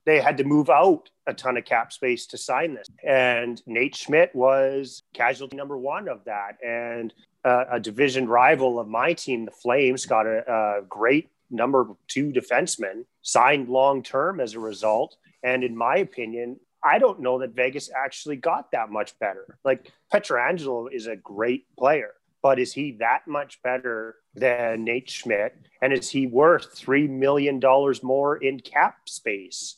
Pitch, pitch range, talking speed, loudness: 130 Hz, 120-140 Hz, 170 wpm, -23 LUFS